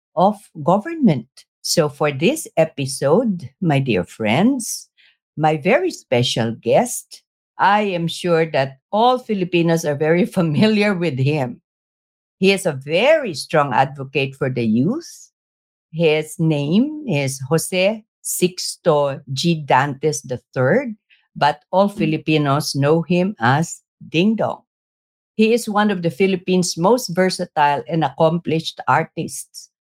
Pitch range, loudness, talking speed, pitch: 145-195 Hz, -18 LUFS, 115 wpm, 165 Hz